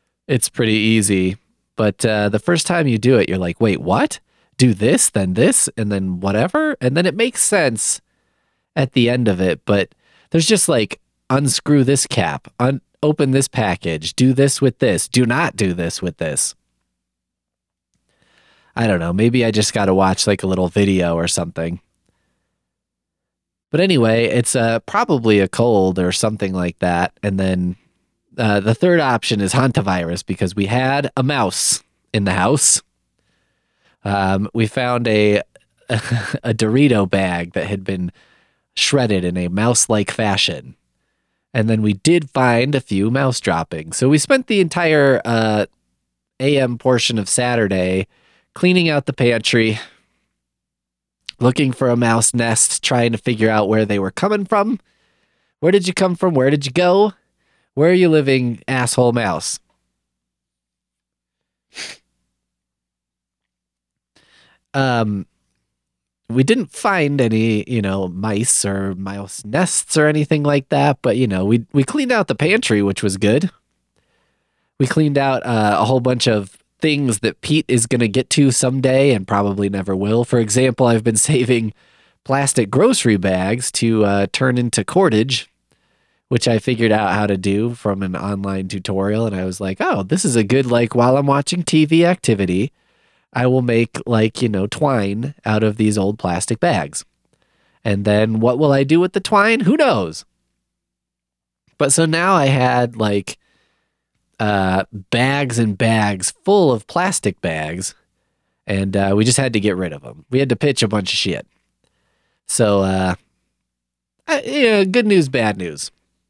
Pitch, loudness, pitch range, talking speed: 110 Hz, -17 LUFS, 95-135 Hz, 165 wpm